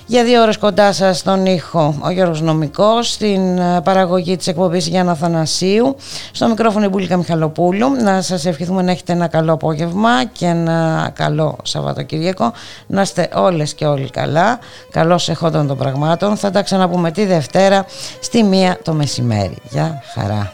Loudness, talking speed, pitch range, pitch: -15 LUFS, 155 wpm, 160-195 Hz, 180 Hz